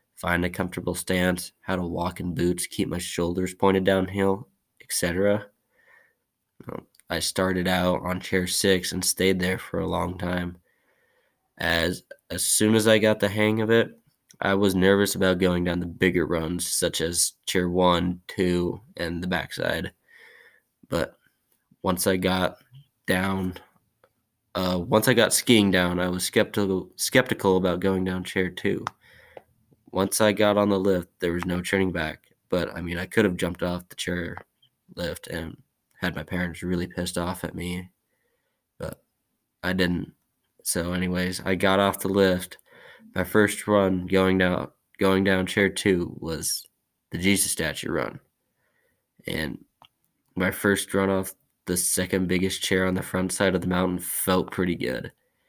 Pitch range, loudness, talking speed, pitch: 90-95 Hz, -25 LUFS, 160 wpm, 90 Hz